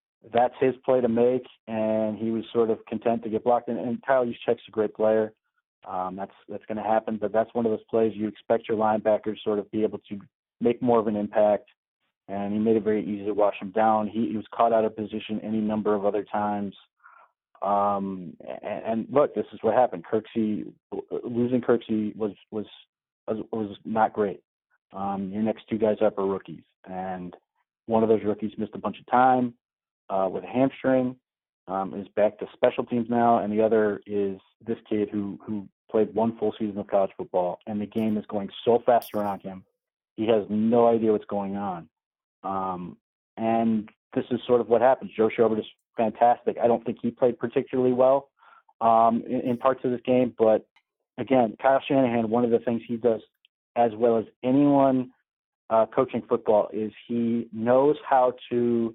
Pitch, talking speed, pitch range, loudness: 110 Hz, 195 wpm, 105-120 Hz, -25 LUFS